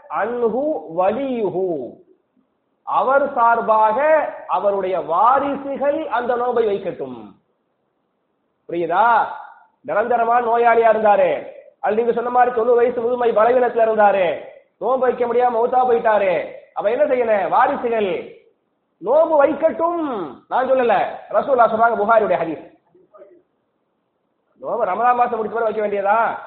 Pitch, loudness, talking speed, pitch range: 245 Hz, -18 LUFS, 100 wpm, 225-280 Hz